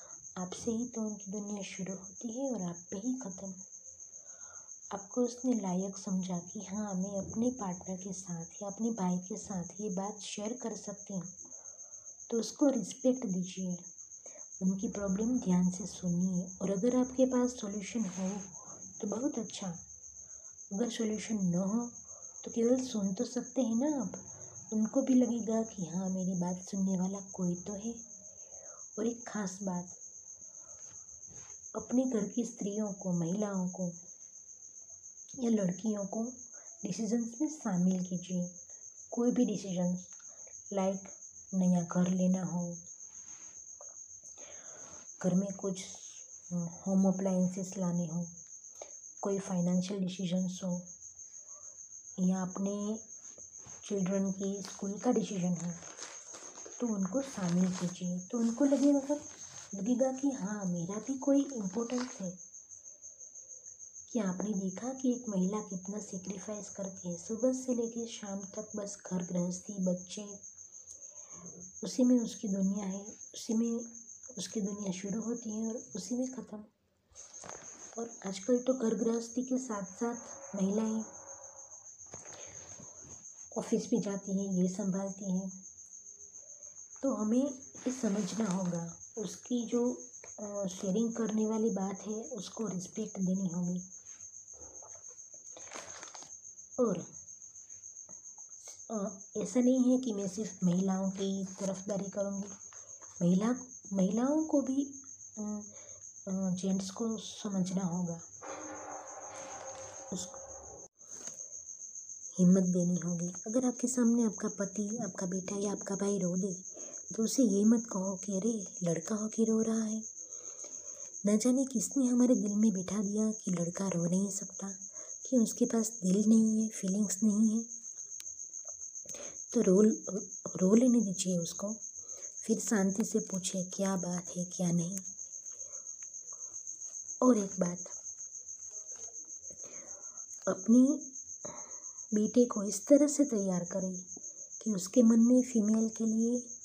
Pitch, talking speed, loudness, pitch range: 205 Hz, 125 wpm, -34 LUFS, 185-230 Hz